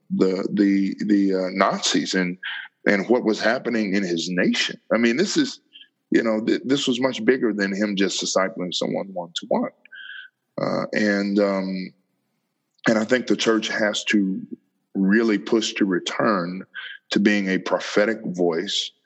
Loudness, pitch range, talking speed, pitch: -22 LUFS, 95-115 Hz, 160 wpm, 105 Hz